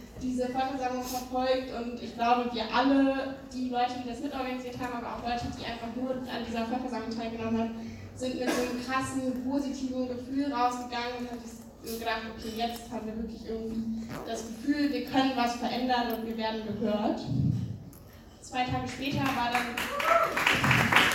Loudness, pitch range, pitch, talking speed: -30 LUFS, 230-255 Hz, 245 Hz, 165 wpm